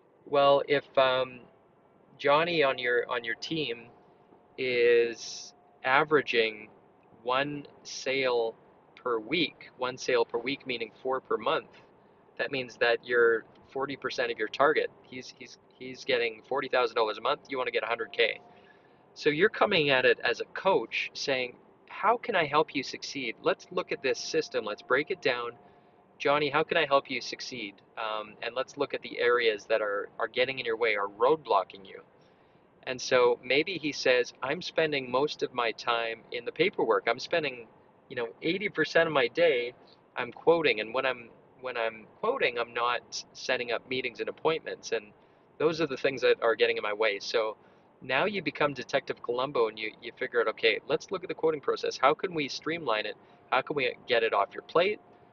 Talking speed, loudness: 185 wpm, -29 LUFS